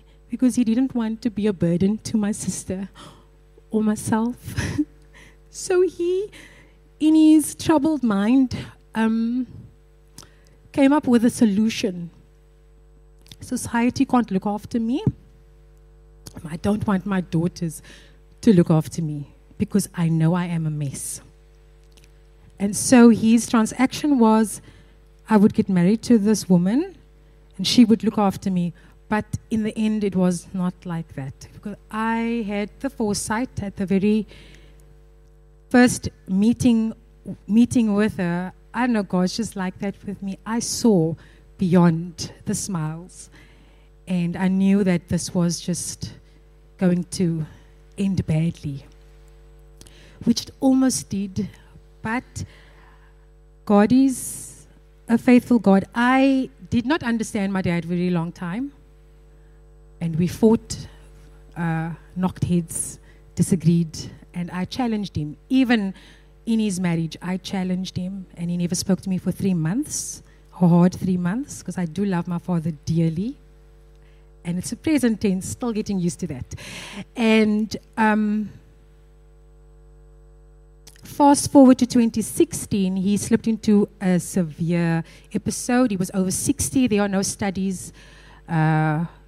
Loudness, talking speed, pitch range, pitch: -21 LUFS, 135 wpm, 155-220 Hz, 185 Hz